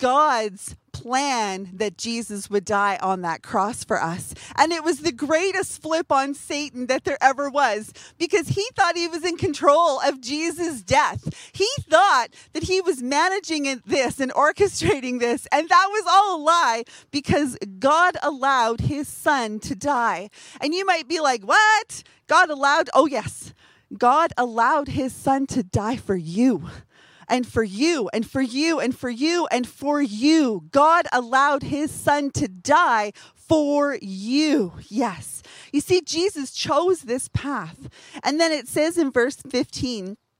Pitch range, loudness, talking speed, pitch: 245-325 Hz, -21 LUFS, 160 wpm, 285 Hz